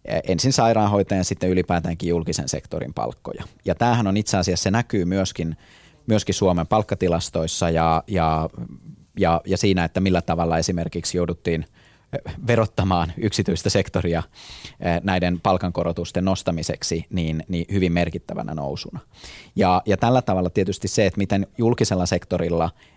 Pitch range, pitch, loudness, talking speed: 85-100 Hz, 90 Hz, -22 LUFS, 130 wpm